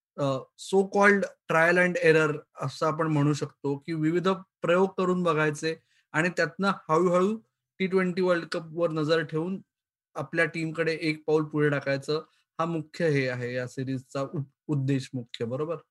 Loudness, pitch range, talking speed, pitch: -27 LUFS, 145-180 Hz, 150 wpm, 160 Hz